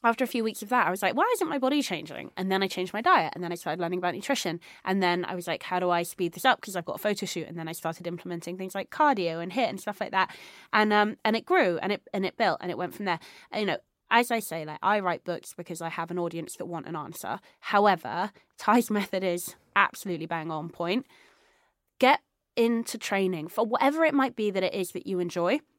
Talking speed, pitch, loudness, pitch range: 265 wpm, 190 Hz, -28 LUFS, 175-230 Hz